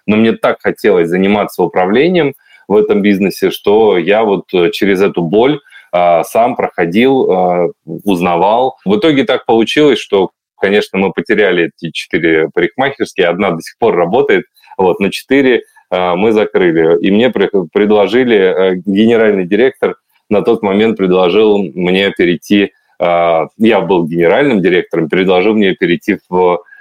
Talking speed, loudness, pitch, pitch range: 145 wpm, -11 LUFS, 105 Hz, 90-150 Hz